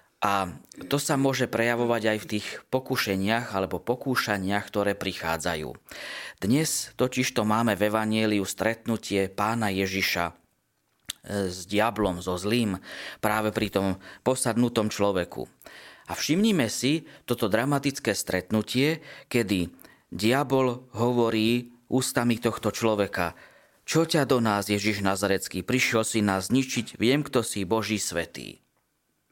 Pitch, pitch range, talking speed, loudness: 110 Hz, 100-120 Hz, 115 wpm, -26 LUFS